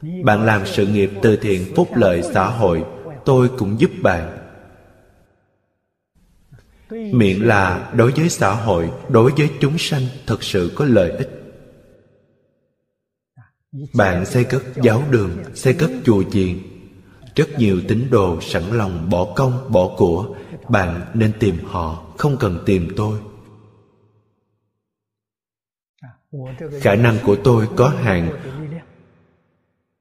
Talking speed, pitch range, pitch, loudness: 125 wpm, 95-130 Hz, 105 Hz, -17 LUFS